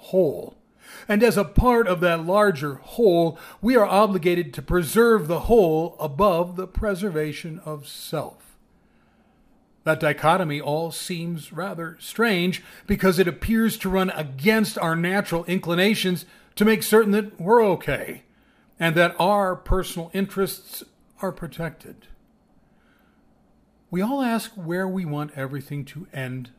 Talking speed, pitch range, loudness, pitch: 130 wpm, 165-210 Hz, -22 LUFS, 185 Hz